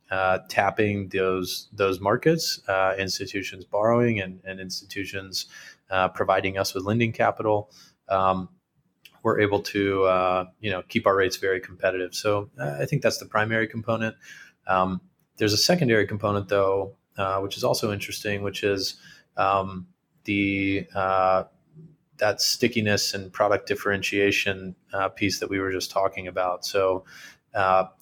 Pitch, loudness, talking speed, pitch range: 100 Hz, -25 LUFS, 145 wpm, 95-105 Hz